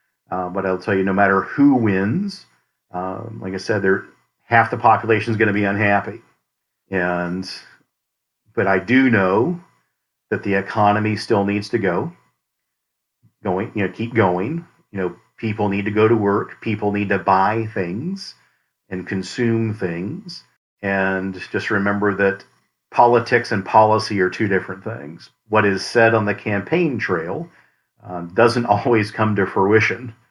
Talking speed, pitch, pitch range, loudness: 155 wpm, 105 Hz, 95-115 Hz, -19 LUFS